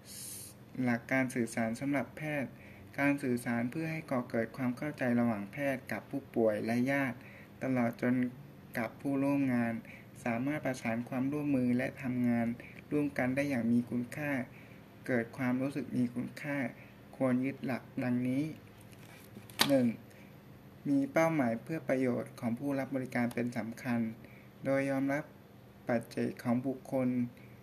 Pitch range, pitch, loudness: 115-140 Hz, 125 Hz, -34 LUFS